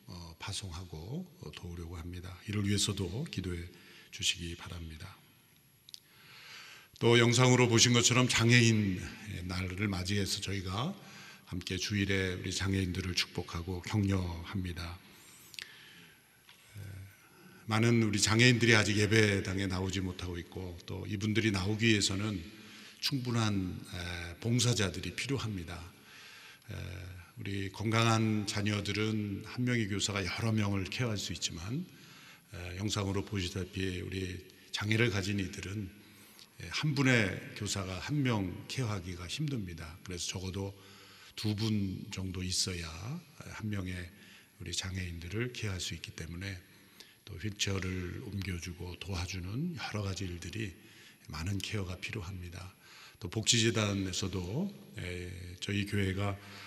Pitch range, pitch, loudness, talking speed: 90-110 Hz, 100 Hz, -33 LUFS, 270 characters per minute